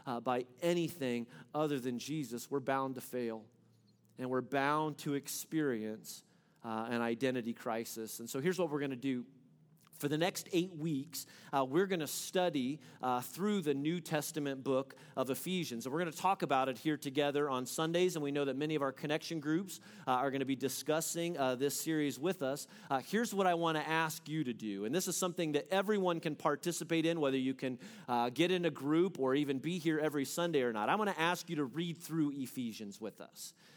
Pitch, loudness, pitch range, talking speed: 150 Hz, -36 LUFS, 130-170 Hz, 215 wpm